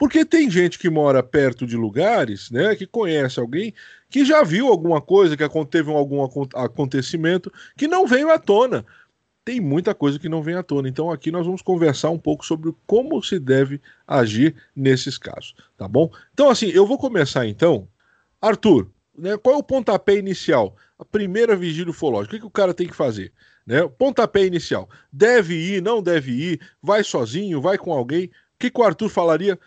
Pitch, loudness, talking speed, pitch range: 175 Hz, -19 LUFS, 190 wpm, 150-210 Hz